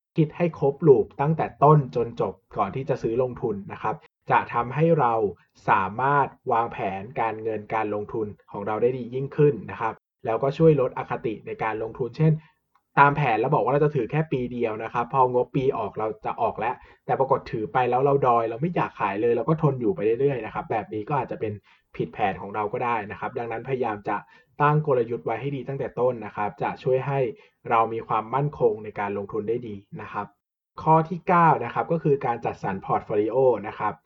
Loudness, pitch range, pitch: -25 LUFS, 115-150 Hz, 130 Hz